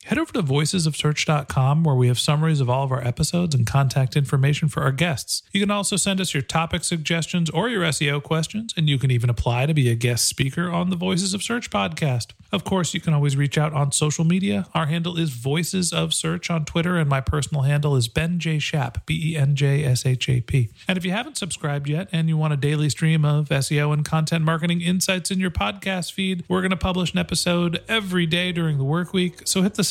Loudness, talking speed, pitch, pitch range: -22 LUFS, 235 wpm, 160 Hz, 145-180 Hz